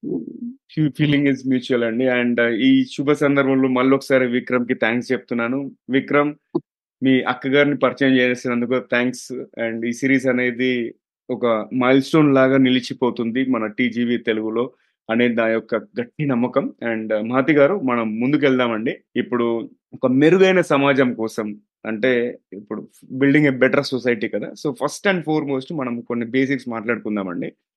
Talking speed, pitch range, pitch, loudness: 140 wpm, 120-140 Hz, 130 Hz, -19 LUFS